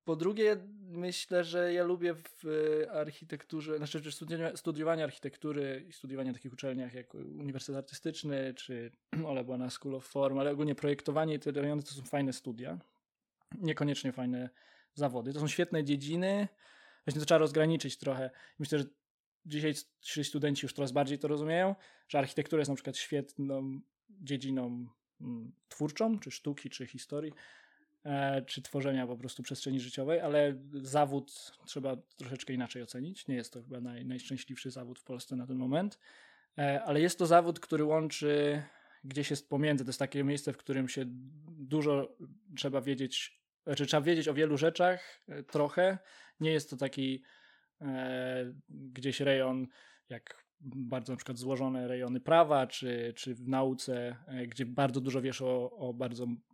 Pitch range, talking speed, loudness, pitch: 130-155 Hz, 155 wpm, -35 LUFS, 140 Hz